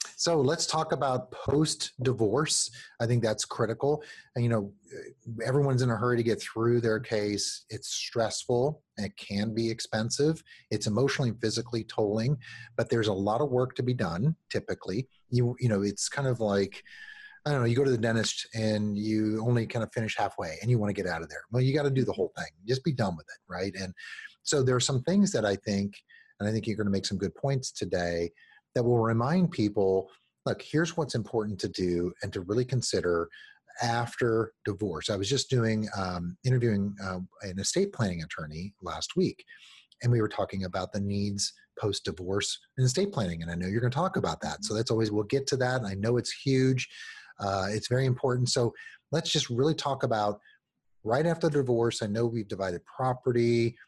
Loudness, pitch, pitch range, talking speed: -29 LUFS, 115 Hz, 105-130 Hz, 210 wpm